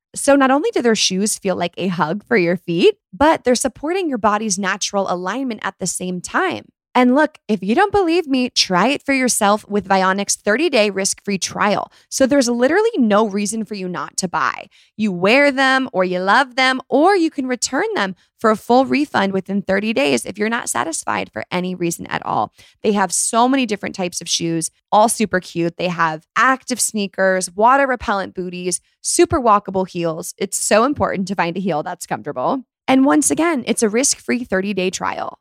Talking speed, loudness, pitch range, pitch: 205 wpm, -17 LUFS, 185-260 Hz, 210 Hz